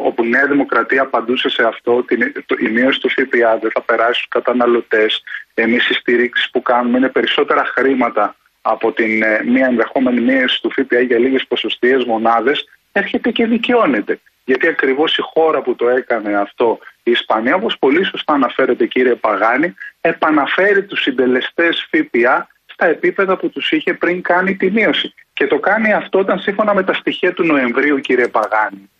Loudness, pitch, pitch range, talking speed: -15 LUFS, 135 Hz, 120-200 Hz, 170 wpm